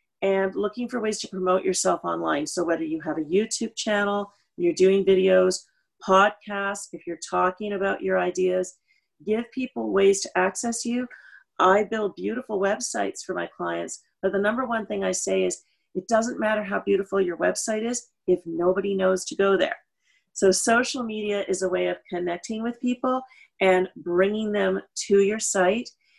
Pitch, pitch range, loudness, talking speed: 195 Hz, 185-225 Hz, -24 LUFS, 175 wpm